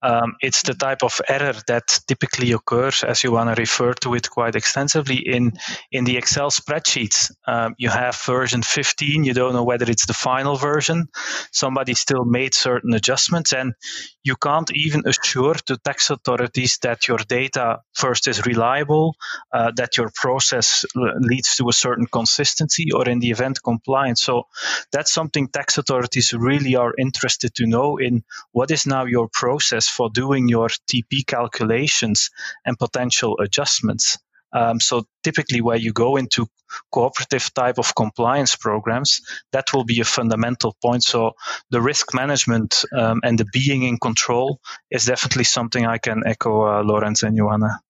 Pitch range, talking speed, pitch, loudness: 115-135 Hz, 165 wpm, 125 Hz, -19 LUFS